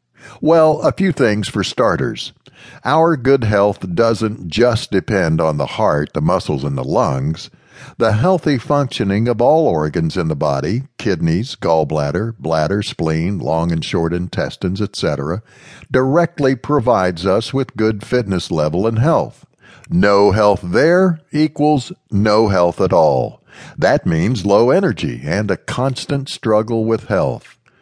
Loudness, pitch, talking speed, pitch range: -16 LUFS, 110 Hz, 140 wpm, 90-135 Hz